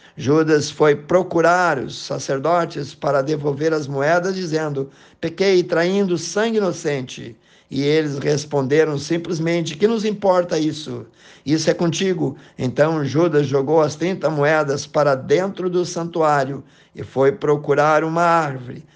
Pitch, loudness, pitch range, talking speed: 155 Hz, -19 LUFS, 145-170 Hz, 125 wpm